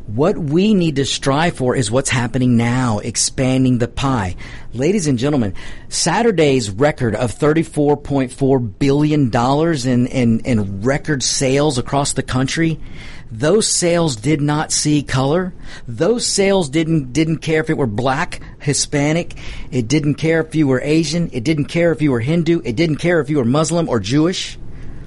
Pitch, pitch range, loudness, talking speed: 140 Hz, 125-160 Hz, -17 LUFS, 165 wpm